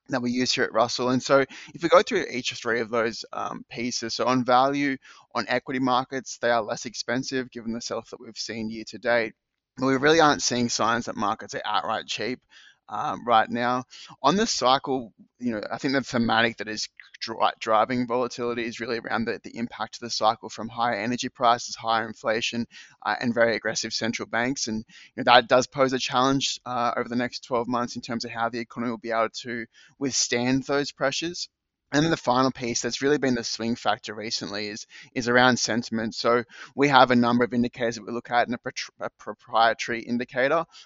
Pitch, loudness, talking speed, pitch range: 120 Hz, -25 LUFS, 215 wpm, 115-130 Hz